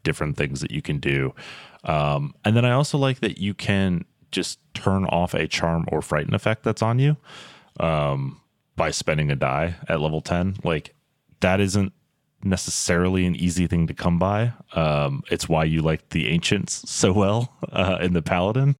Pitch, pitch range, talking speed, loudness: 90 Hz, 80-100 Hz, 180 wpm, -23 LUFS